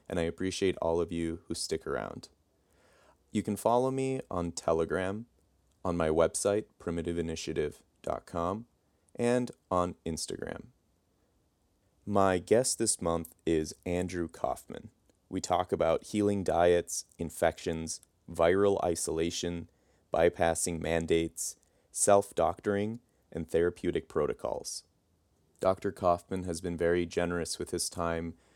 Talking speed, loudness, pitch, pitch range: 110 wpm, -31 LUFS, 85 Hz, 85-100 Hz